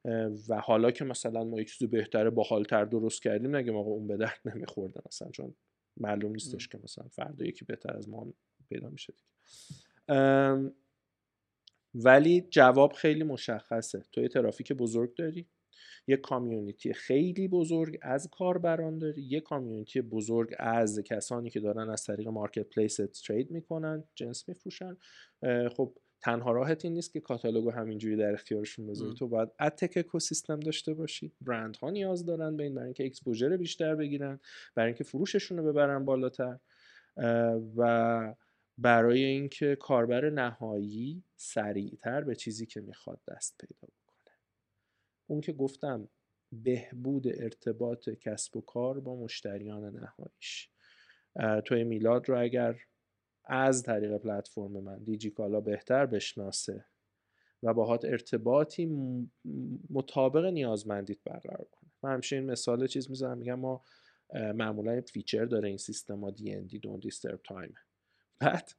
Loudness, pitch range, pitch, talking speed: -32 LUFS, 110-140 Hz, 120 Hz, 140 wpm